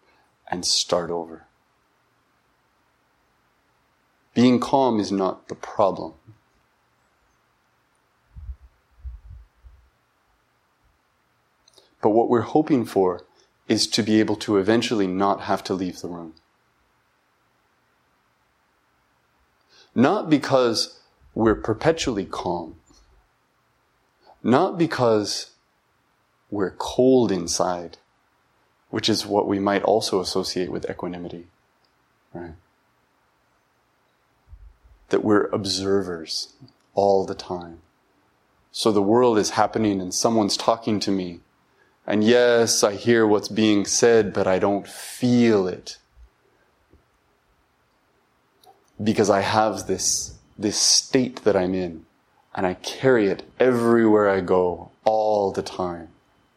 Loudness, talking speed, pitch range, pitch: -21 LUFS, 100 wpm, 85-110 Hz, 100 Hz